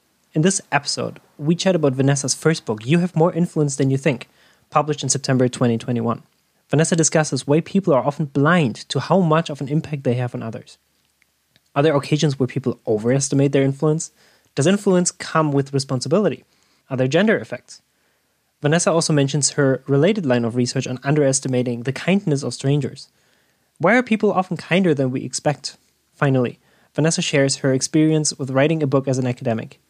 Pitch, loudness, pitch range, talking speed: 140 Hz, -19 LUFS, 130-160 Hz, 175 wpm